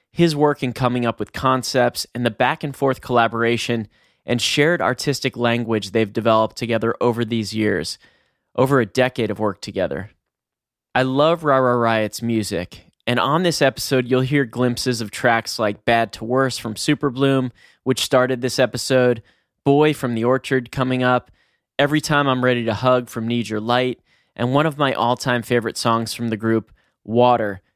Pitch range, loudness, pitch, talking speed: 115-130 Hz, -20 LUFS, 120 Hz, 175 wpm